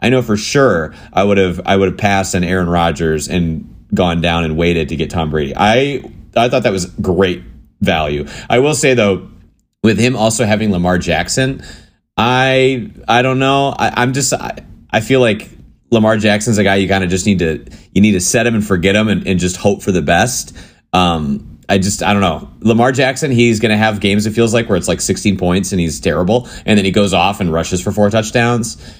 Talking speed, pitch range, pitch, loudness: 225 wpm, 90-115 Hz, 100 Hz, -14 LUFS